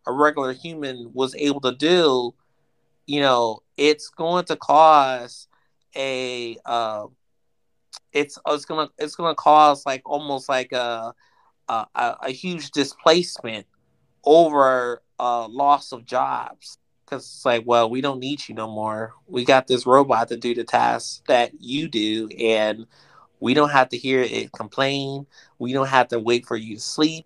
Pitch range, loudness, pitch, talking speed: 120-145 Hz, -21 LUFS, 130 Hz, 160 wpm